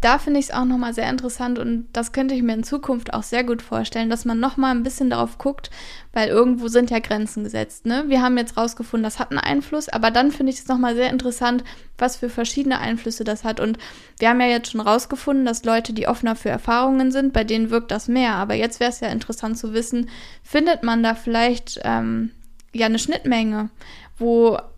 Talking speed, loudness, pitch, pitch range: 230 wpm, -21 LUFS, 235 Hz, 225-250 Hz